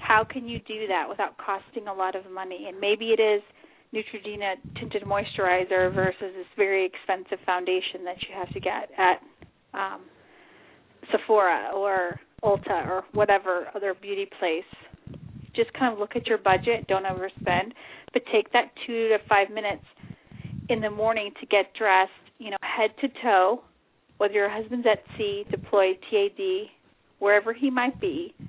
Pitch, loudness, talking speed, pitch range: 205 Hz, -26 LUFS, 165 wpm, 190-230 Hz